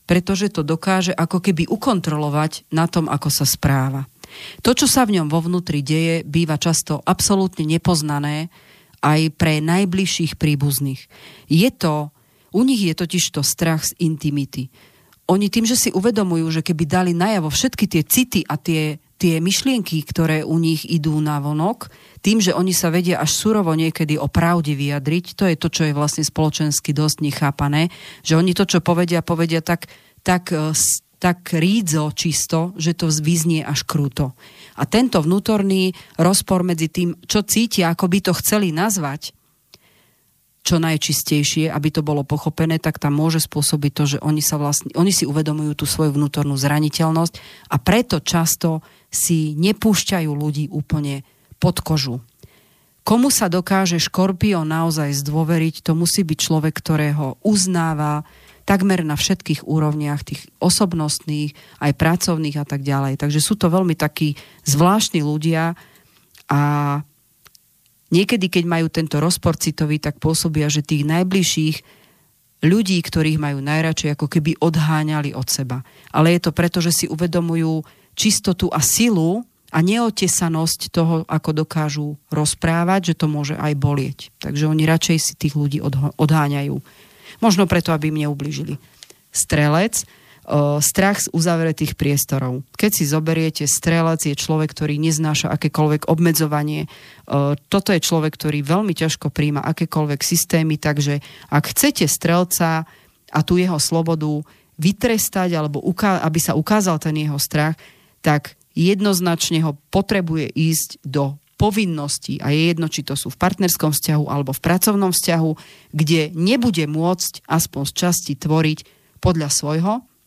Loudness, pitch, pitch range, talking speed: -19 LUFS, 160 Hz, 150-175 Hz, 145 wpm